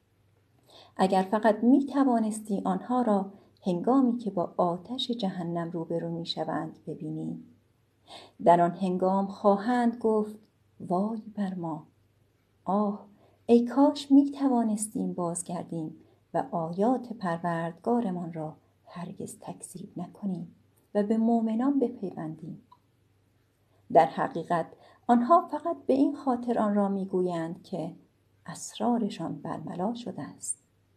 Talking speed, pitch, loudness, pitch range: 105 wpm, 185 Hz, -28 LUFS, 165-225 Hz